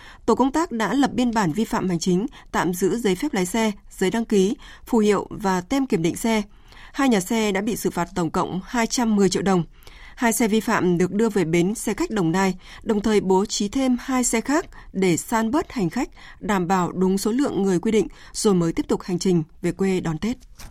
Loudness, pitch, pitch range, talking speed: -22 LUFS, 205 Hz, 185-230 Hz, 240 wpm